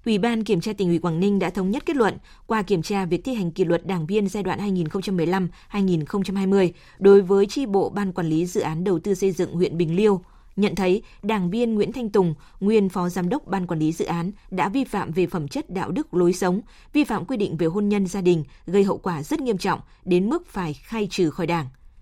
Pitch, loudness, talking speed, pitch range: 190 Hz, -23 LUFS, 245 wpm, 175-205 Hz